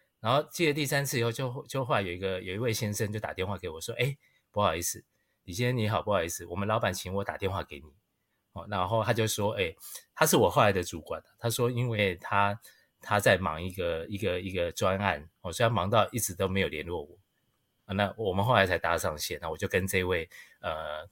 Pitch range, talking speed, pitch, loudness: 95-115 Hz, 330 characters per minute, 100 Hz, -29 LUFS